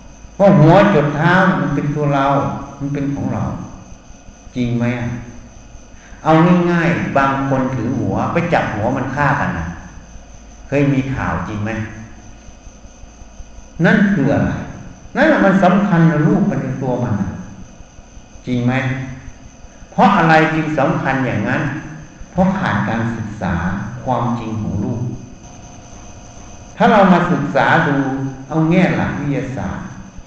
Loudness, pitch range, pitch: -16 LUFS, 110-160 Hz, 135 Hz